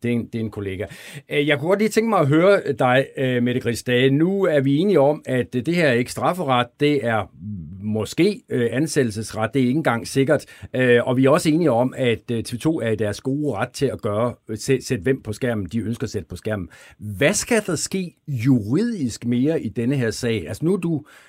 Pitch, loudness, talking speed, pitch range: 125 Hz, -21 LUFS, 225 wpm, 115-145 Hz